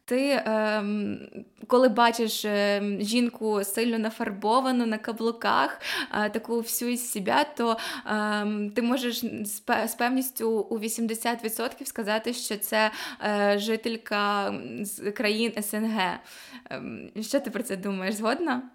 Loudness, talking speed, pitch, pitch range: -27 LUFS, 100 wpm, 225 Hz, 210-235 Hz